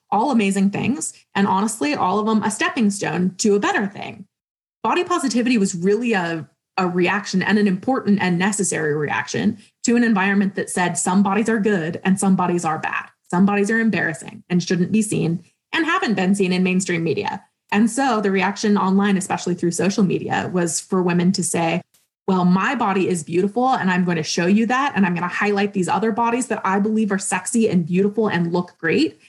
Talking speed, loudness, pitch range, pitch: 205 wpm, -20 LUFS, 180-220 Hz, 195 Hz